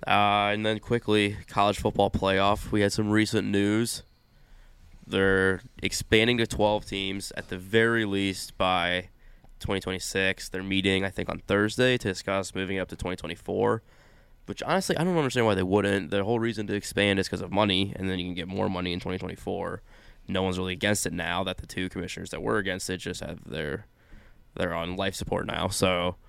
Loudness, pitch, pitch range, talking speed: -27 LUFS, 95 Hz, 95-105 Hz, 190 wpm